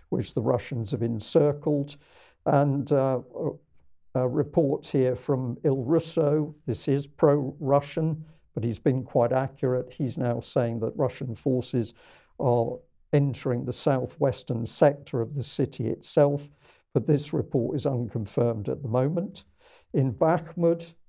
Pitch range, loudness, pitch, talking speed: 125-150 Hz, -27 LUFS, 140 Hz, 135 wpm